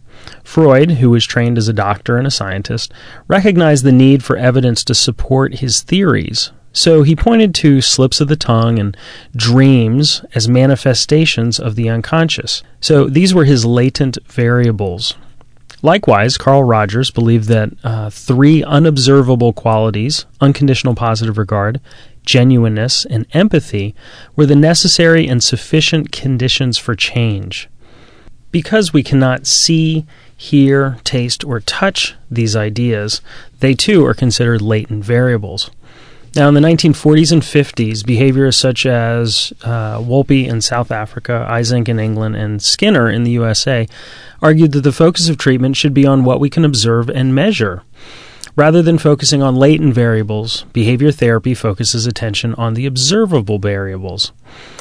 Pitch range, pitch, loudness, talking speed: 115-145 Hz, 125 Hz, -12 LUFS, 140 wpm